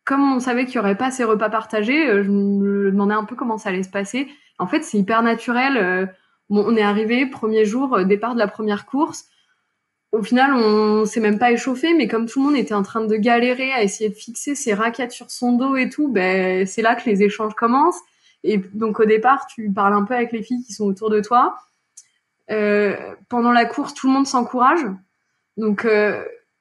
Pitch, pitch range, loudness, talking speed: 225 Hz, 210-255 Hz, -19 LUFS, 220 wpm